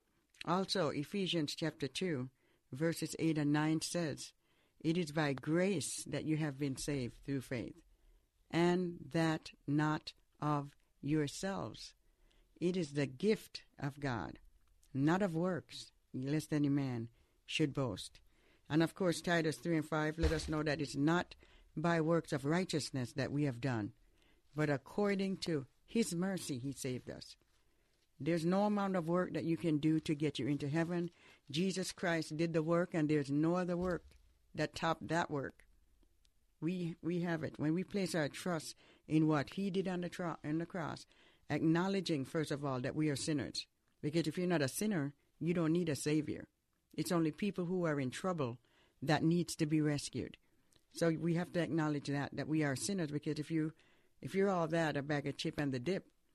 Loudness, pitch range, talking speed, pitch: -37 LUFS, 145-170 Hz, 180 wpm, 155 Hz